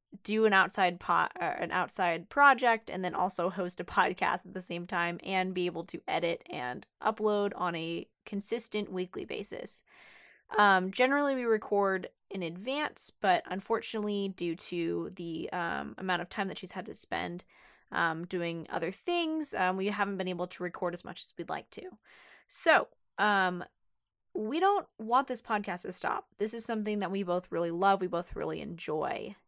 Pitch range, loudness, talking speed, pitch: 175-215 Hz, -31 LUFS, 180 wpm, 190 Hz